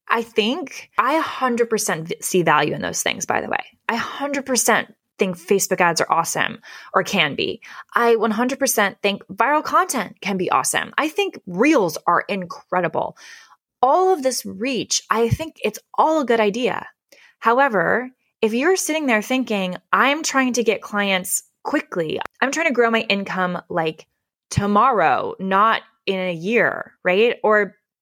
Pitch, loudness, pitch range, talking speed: 230 Hz, -20 LUFS, 200-265 Hz, 155 wpm